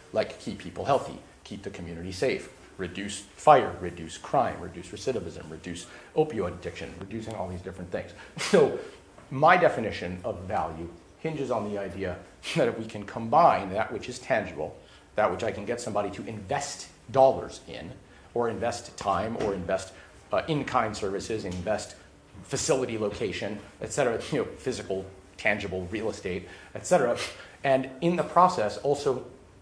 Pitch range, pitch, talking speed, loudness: 90-115 Hz, 100 Hz, 155 wpm, -28 LUFS